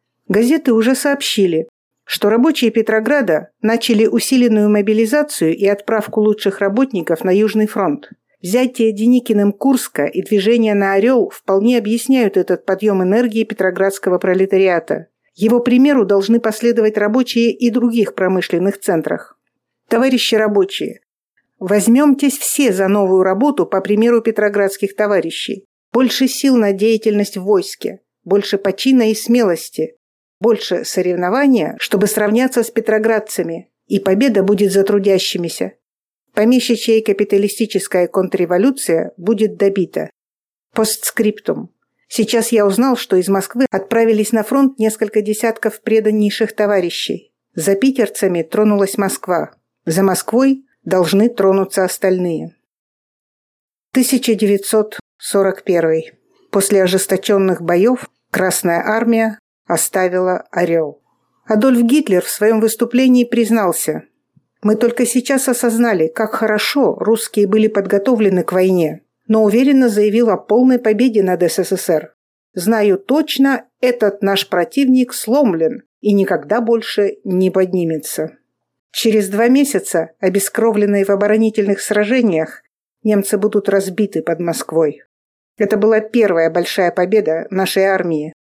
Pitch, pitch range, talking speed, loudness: 210 Hz, 190-230 Hz, 110 wpm, -15 LUFS